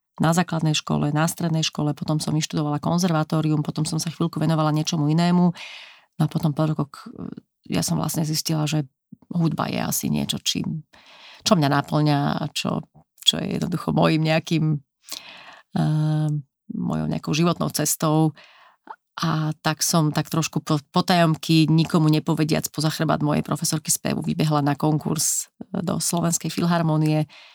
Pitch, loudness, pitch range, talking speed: 155 Hz, -22 LUFS, 155-165 Hz, 145 wpm